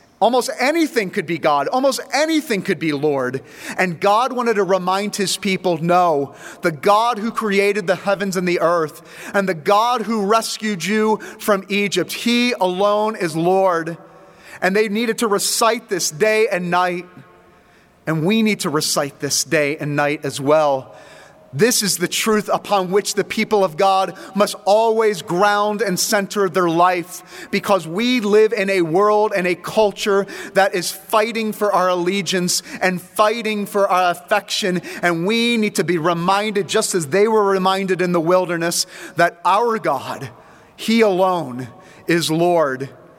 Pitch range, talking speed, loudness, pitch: 175-210 Hz, 165 wpm, -18 LUFS, 195 Hz